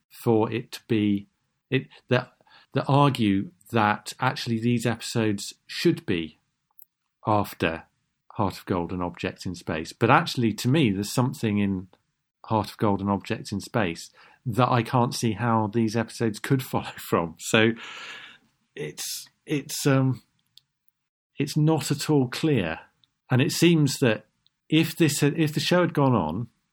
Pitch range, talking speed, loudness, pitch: 105-140 Hz, 145 wpm, -25 LUFS, 120 Hz